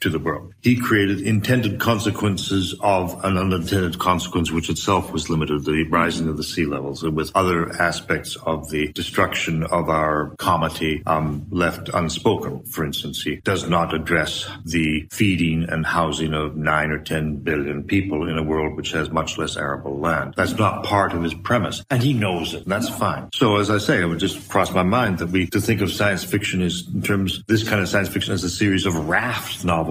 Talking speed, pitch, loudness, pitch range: 210 wpm, 90 Hz, -21 LUFS, 80-100 Hz